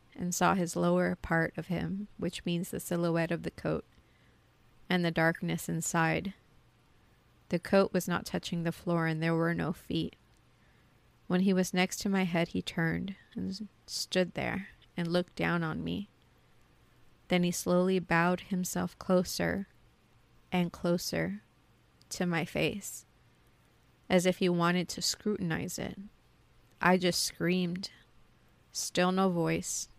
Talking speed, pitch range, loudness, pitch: 140 wpm, 165-185 Hz, -31 LUFS, 175 Hz